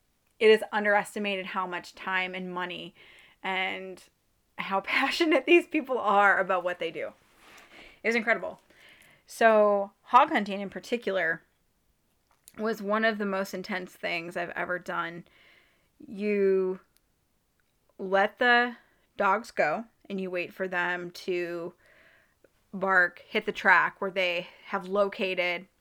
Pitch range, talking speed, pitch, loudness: 185-220 Hz, 125 wpm, 195 Hz, -27 LUFS